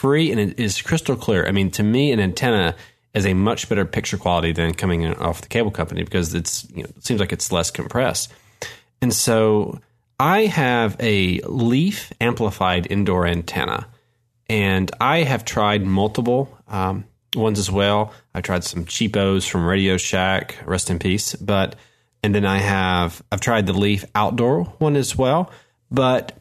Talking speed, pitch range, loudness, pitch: 175 wpm, 95-120 Hz, -20 LUFS, 105 Hz